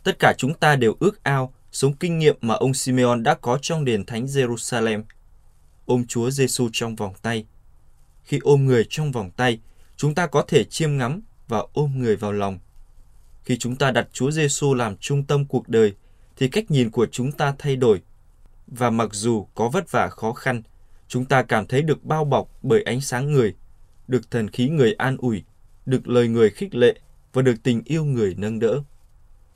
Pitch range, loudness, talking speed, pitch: 110-140 Hz, -22 LUFS, 200 wpm, 120 Hz